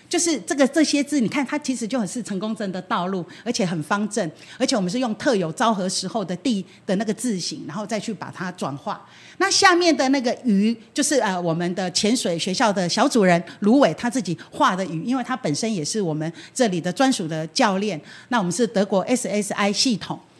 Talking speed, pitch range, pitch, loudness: 325 characters per minute, 185-255 Hz, 215 Hz, -22 LUFS